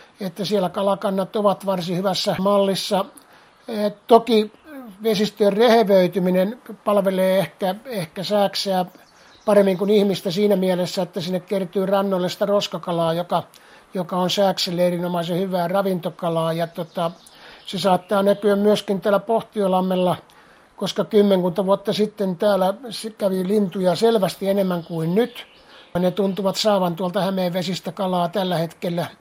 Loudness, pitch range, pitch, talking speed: -21 LUFS, 185-205 Hz, 195 Hz, 125 wpm